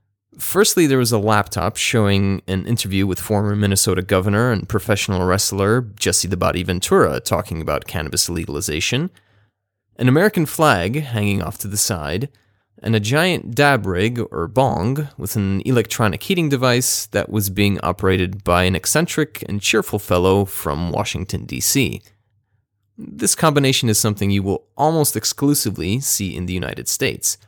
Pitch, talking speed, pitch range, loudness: 105 Hz, 150 wpm, 95-120 Hz, -18 LUFS